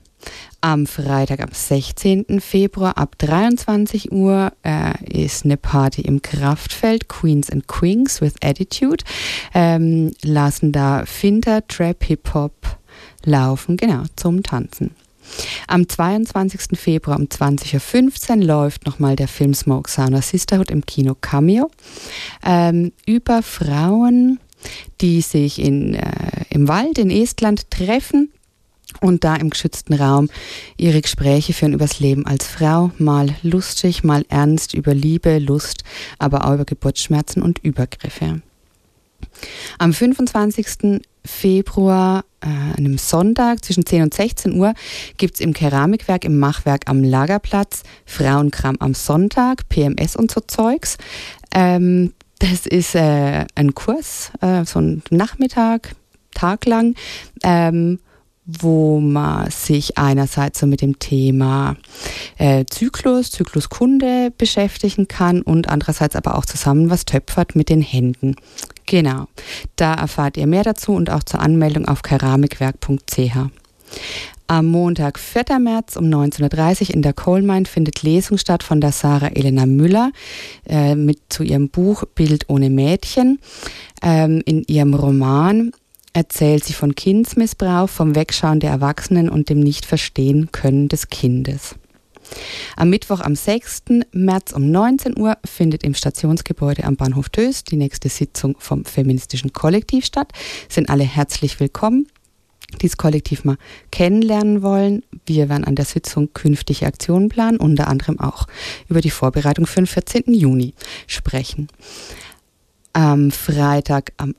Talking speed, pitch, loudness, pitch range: 130 wpm, 160 Hz, -17 LUFS, 145-195 Hz